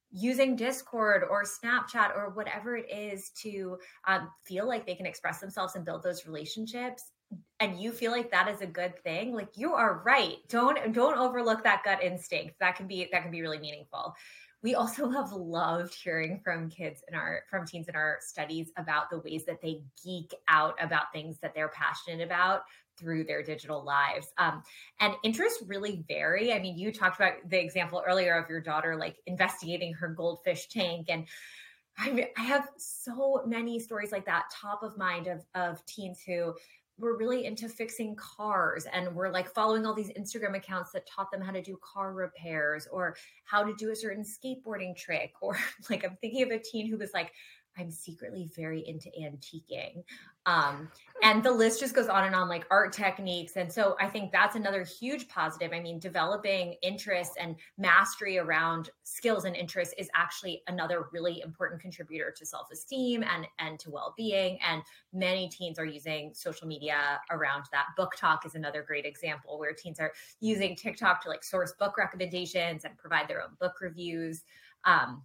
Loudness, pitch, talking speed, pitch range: -31 LUFS, 185 Hz, 190 wpm, 165-210 Hz